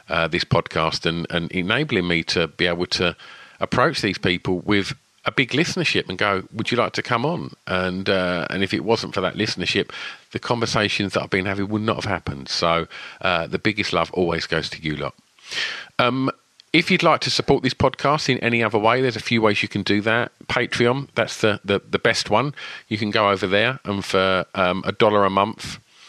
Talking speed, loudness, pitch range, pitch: 215 wpm, -21 LUFS, 95-125 Hz, 100 Hz